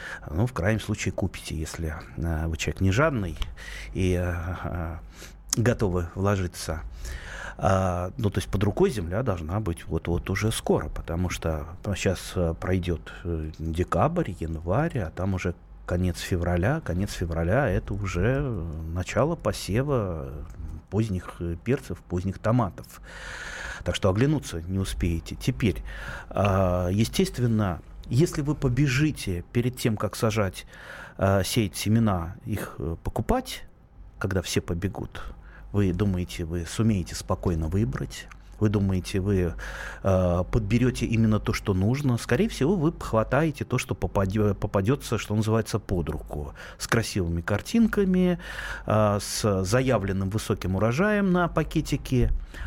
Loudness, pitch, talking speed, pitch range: -27 LUFS, 95 Hz, 120 wpm, 85-115 Hz